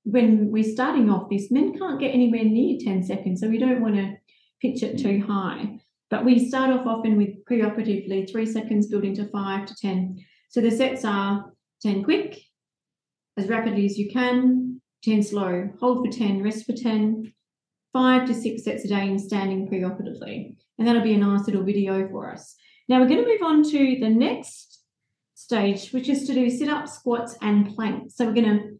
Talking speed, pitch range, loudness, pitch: 200 wpm, 200-250 Hz, -23 LUFS, 225 Hz